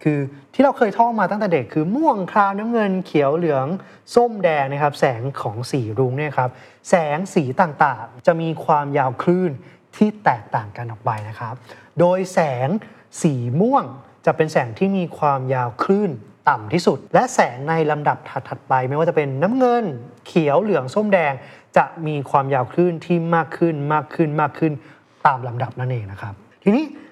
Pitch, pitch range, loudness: 155 Hz, 130-185 Hz, -20 LUFS